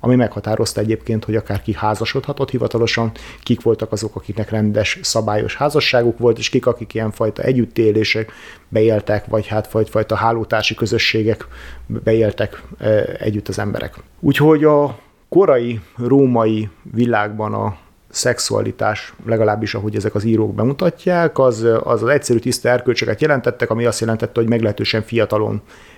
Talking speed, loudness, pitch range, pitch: 130 wpm, -17 LUFS, 105-120 Hz, 110 Hz